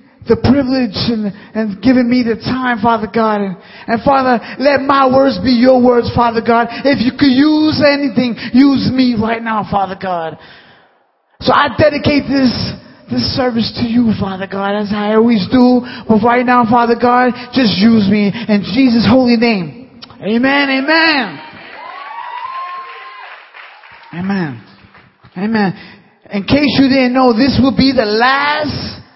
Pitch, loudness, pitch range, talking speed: 245 Hz, -12 LUFS, 215-265 Hz, 150 wpm